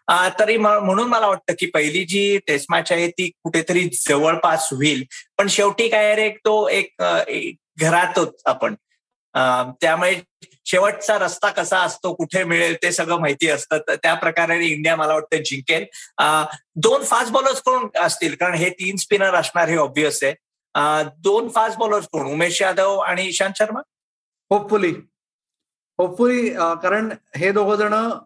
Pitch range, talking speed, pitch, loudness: 165-210 Hz, 140 wpm, 180 Hz, -19 LUFS